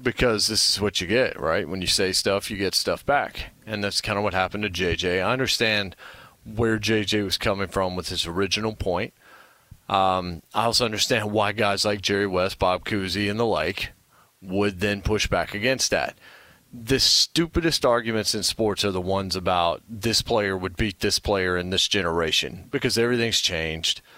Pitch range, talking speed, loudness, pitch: 95-110 Hz, 185 wpm, -23 LUFS, 105 Hz